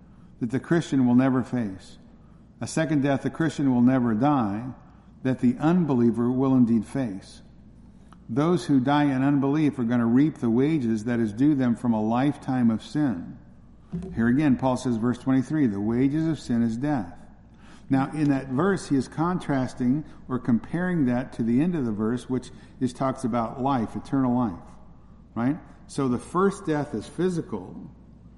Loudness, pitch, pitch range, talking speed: -25 LUFS, 130 Hz, 120-145 Hz, 175 wpm